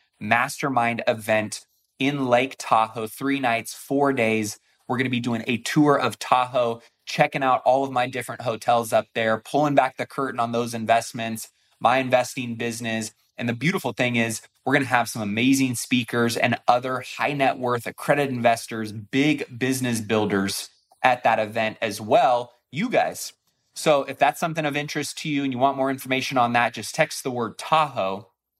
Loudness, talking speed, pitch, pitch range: -23 LUFS, 180 wpm, 125 Hz, 115-135 Hz